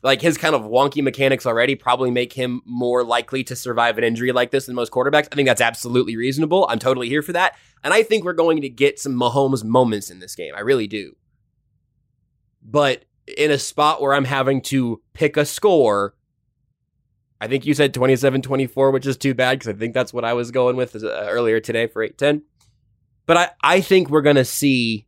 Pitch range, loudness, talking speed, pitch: 120-140 Hz, -19 LUFS, 220 wpm, 130 Hz